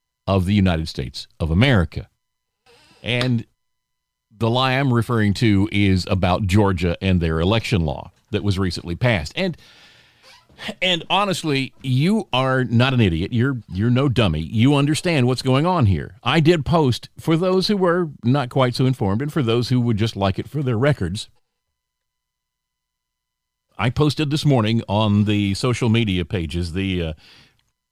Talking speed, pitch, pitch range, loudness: 165 wpm, 115 Hz, 100-135 Hz, -20 LUFS